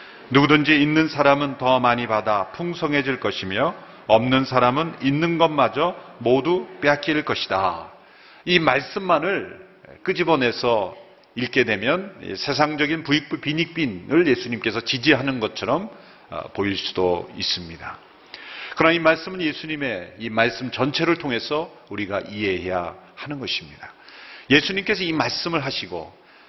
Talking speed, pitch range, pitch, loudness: 290 characters per minute, 120-160 Hz, 140 Hz, -21 LUFS